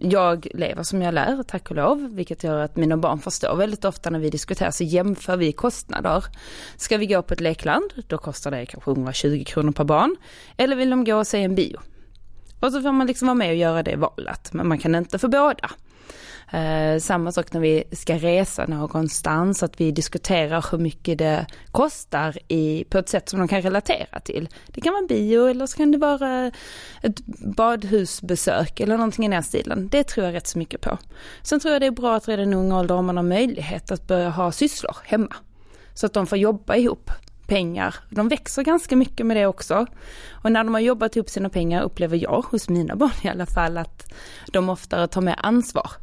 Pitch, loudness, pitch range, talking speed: 185 Hz, -22 LUFS, 165-225 Hz, 220 wpm